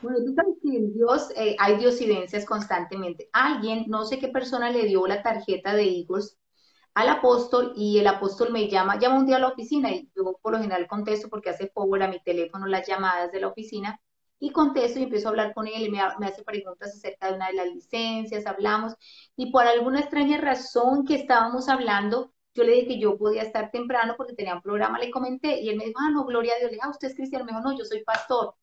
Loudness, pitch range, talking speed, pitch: -25 LUFS, 205-255 Hz, 230 wpm, 220 Hz